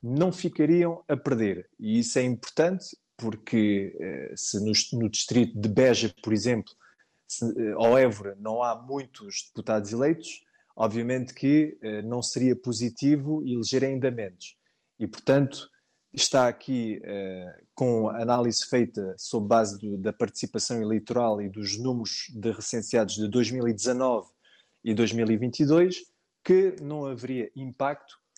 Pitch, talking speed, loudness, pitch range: 120 Hz, 135 wpm, -27 LUFS, 110-135 Hz